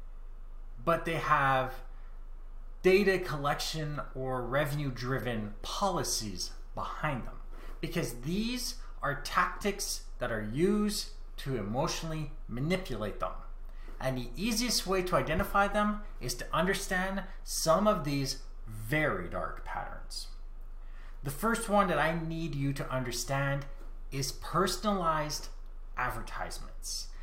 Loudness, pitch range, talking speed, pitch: -32 LUFS, 130-190 Hz, 110 wpm, 150 Hz